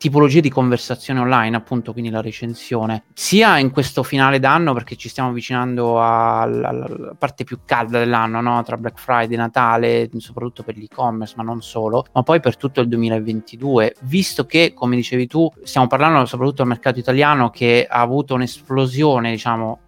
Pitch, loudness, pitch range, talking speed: 125 Hz, -17 LUFS, 115-135 Hz, 165 wpm